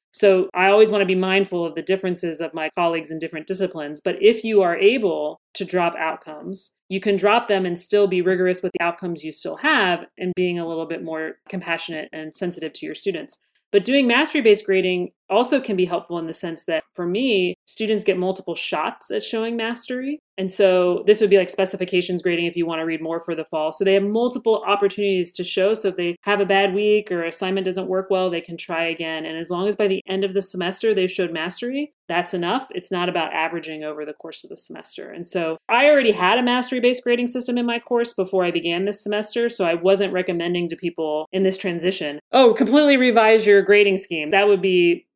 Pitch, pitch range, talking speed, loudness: 185 Hz, 170-205 Hz, 230 wpm, -20 LUFS